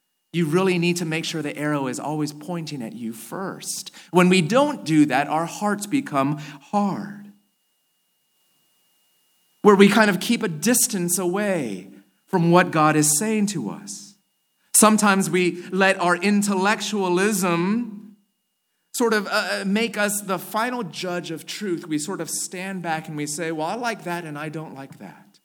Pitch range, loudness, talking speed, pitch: 160-205 Hz, -21 LUFS, 165 wpm, 185 Hz